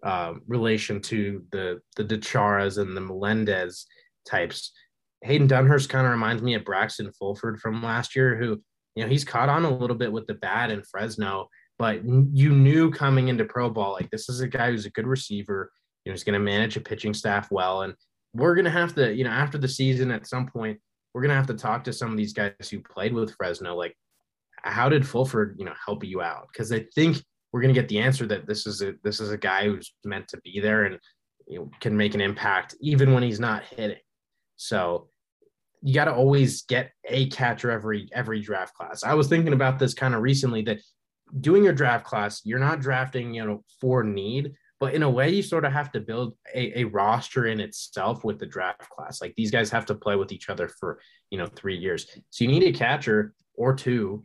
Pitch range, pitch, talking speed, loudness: 105-135 Hz, 120 Hz, 230 wpm, -25 LUFS